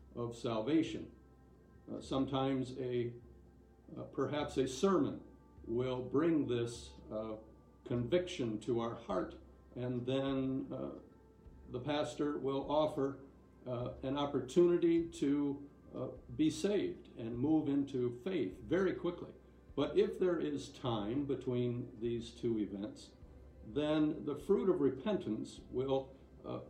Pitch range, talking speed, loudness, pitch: 120-150 Hz, 120 wpm, -37 LUFS, 135 Hz